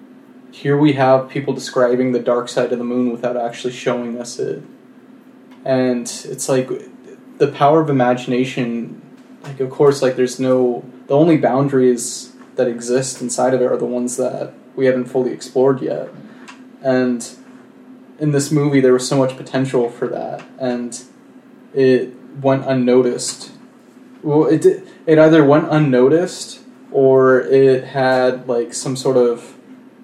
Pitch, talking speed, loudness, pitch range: 130 Hz, 150 wpm, -16 LUFS, 125-145 Hz